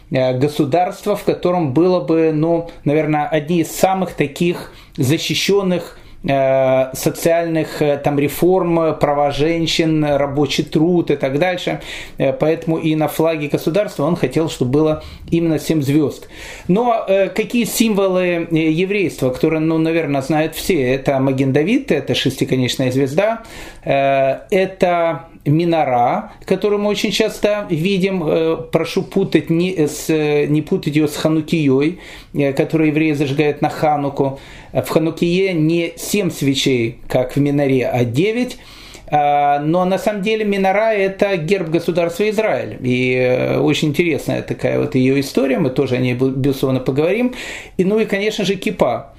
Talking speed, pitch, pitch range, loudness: 140 wpm, 160 Hz, 145-180 Hz, -17 LUFS